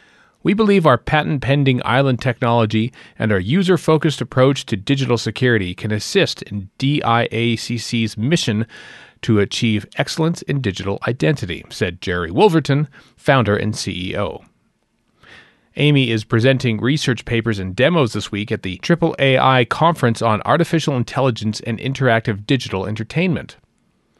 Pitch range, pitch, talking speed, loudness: 110-140 Hz, 120 Hz, 130 wpm, -18 LUFS